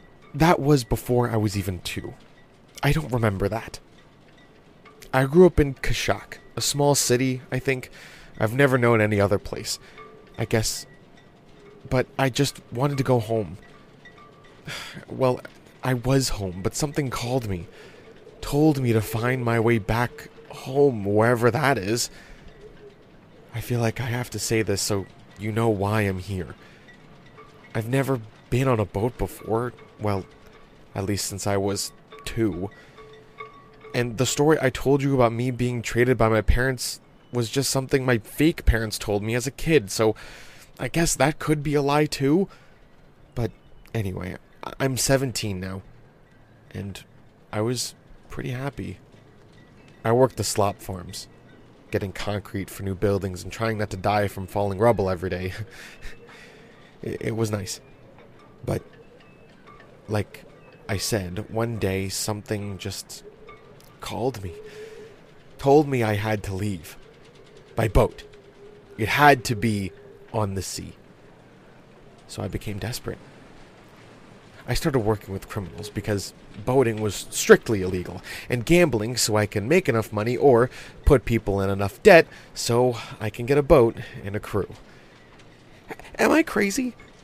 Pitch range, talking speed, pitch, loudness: 105-135 Hz, 150 wpm, 115 Hz, -24 LUFS